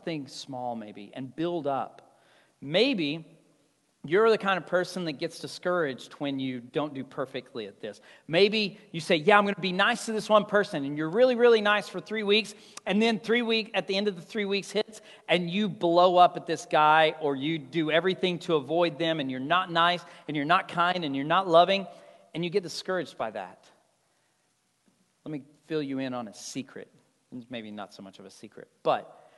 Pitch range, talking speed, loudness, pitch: 150-195 Hz, 210 wpm, -26 LUFS, 170 Hz